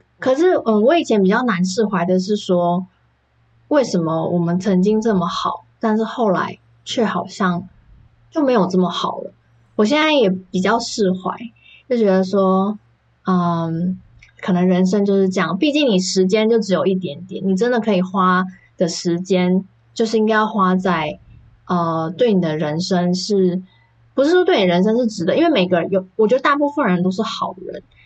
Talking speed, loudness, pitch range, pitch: 255 characters per minute, -18 LUFS, 175-220 Hz, 185 Hz